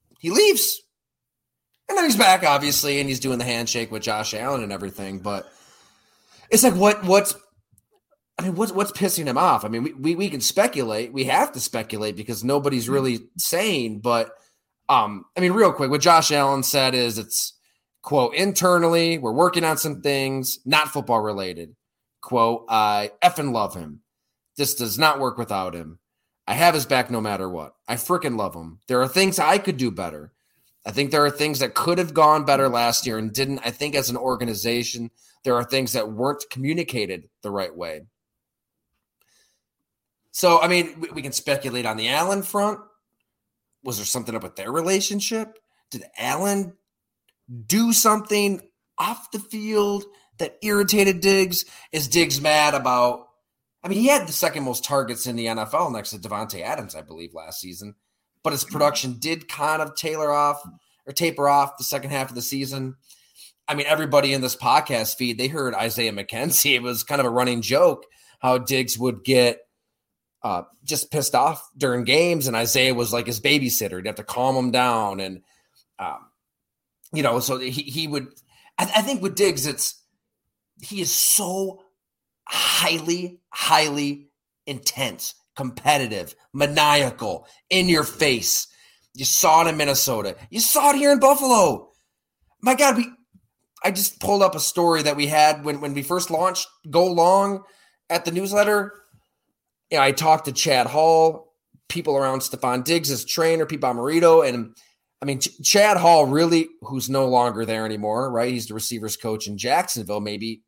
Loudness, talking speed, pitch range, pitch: -21 LUFS, 175 wpm, 120-175 Hz, 140 Hz